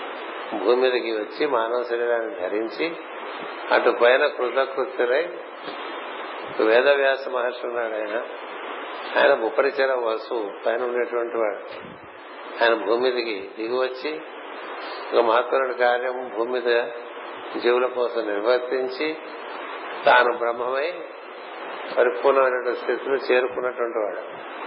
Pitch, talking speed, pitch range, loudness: 125 Hz, 80 wpm, 120-135 Hz, -23 LUFS